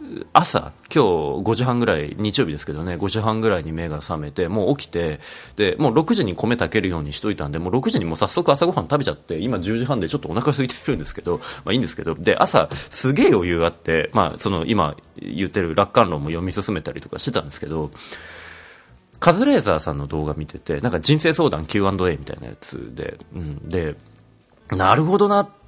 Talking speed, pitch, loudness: 405 characters per minute, 100 Hz, -21 LUFS